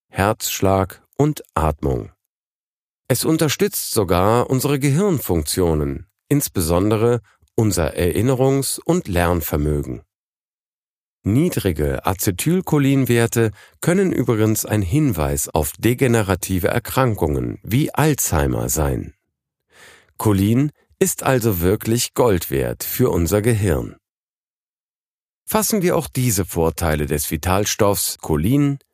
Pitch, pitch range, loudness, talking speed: 105 Hz, 85-135 Hz, -19 LUFS, 85 wpm